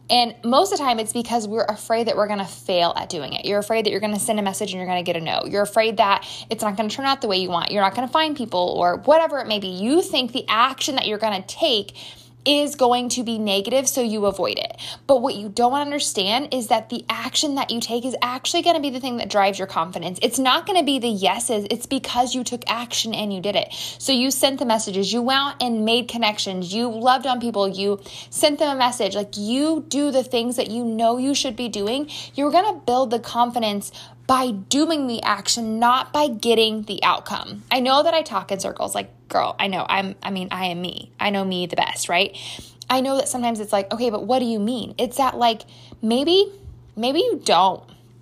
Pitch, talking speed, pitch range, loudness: 235 Hz, 245 wpm, 205-260 Hz, -21 LUFS